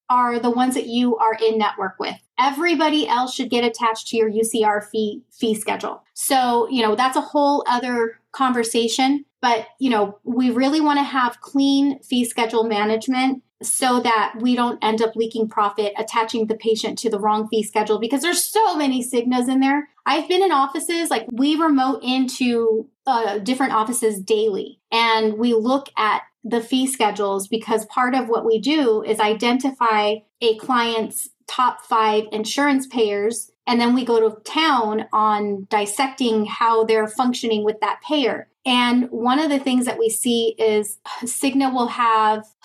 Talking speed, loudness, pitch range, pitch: 170 wpm, -20 LUFS, 220-265 Hz, 235 Hz